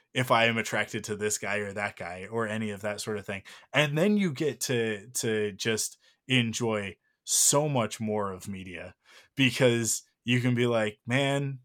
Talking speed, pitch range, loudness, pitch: 185 wpm, 105-125 Hz, -28 LUFS, 115 Hz